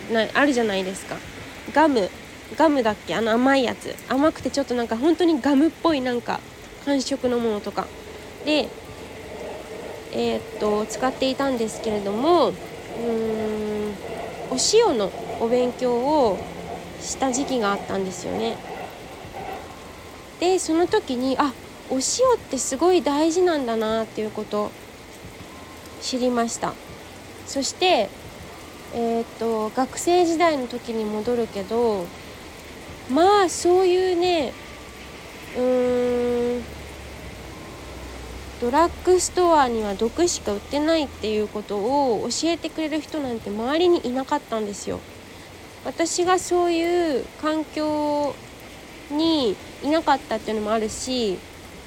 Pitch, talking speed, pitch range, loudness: 255 Hz, 250 characters per minute, 225-320 Hz, -23 LUFS